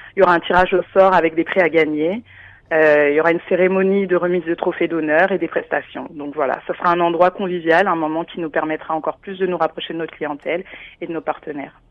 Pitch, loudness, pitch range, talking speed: 170 Hz, -18 LUFS, 160-180 Hz, 250 wpm